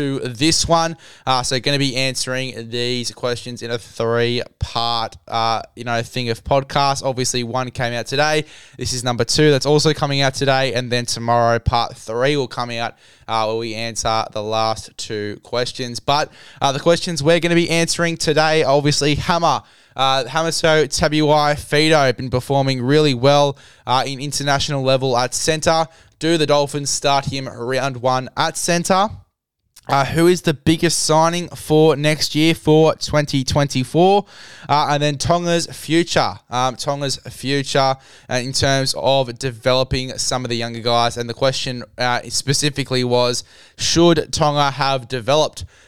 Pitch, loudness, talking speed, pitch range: 135 Hz, -18 LUFS, 165 wpm, 120-150 Hz